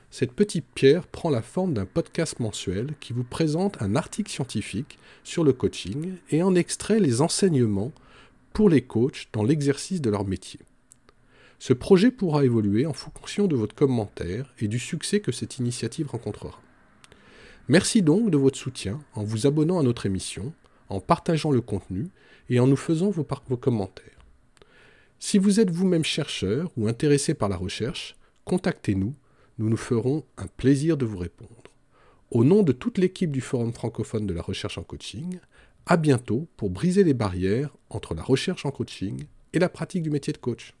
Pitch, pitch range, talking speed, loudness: 135 Hz, 110-165 Hz, 175 wpm, -25 LUFS